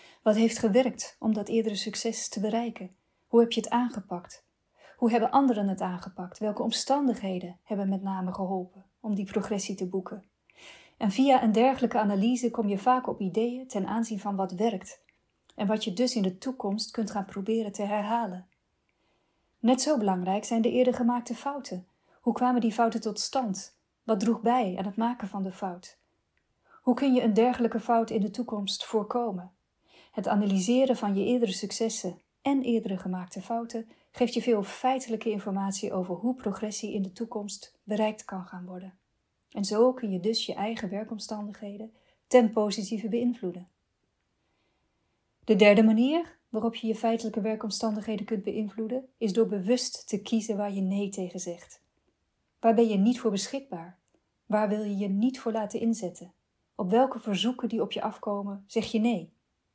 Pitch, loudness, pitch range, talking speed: 220 Hz, -28 LUFS, 200-235 Hz, 170 wpm